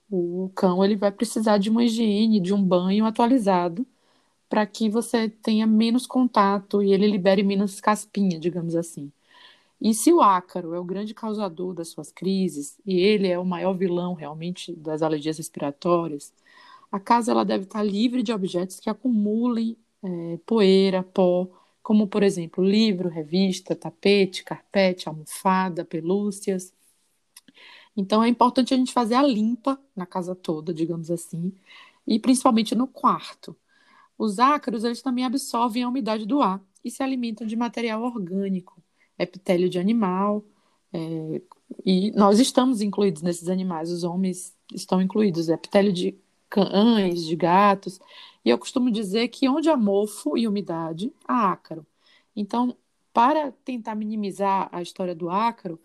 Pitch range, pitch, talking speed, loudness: 180-230 Hz, 200 Hz, 150 wpm, -23 LUFS